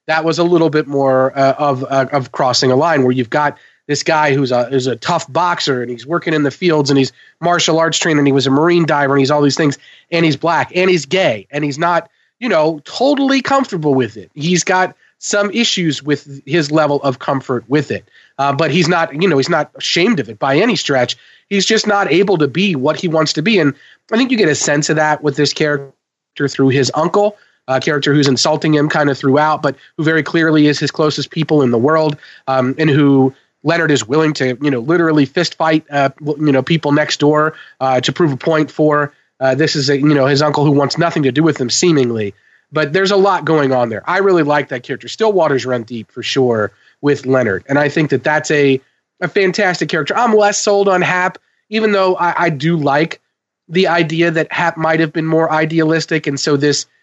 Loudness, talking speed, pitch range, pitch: -14 LUFS, 235 wpm, 140-170 Hz, 150 Hz